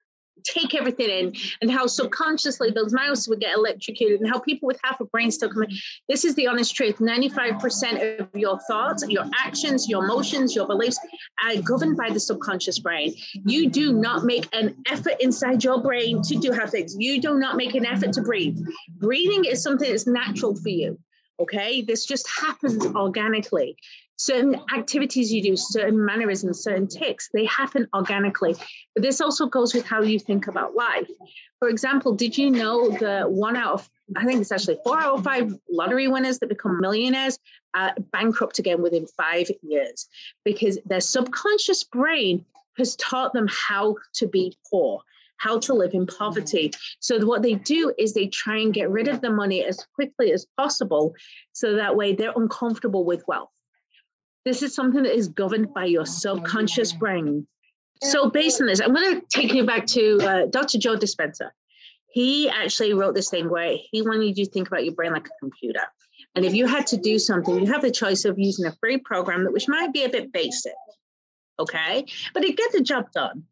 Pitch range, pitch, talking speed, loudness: 200-265 Hz, 230 Hz, 195 wpm, -23 LUFS